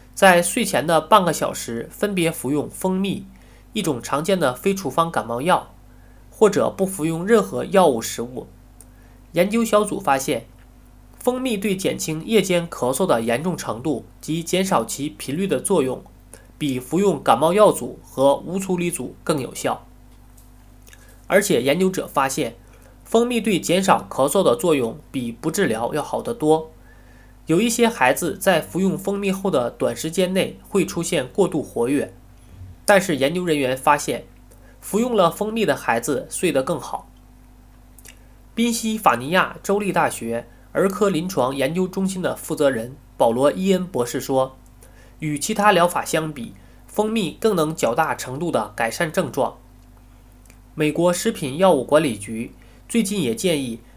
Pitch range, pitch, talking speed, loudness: 120-185 Hz, 150 Hz, 235 characters per minute, -21 LUFS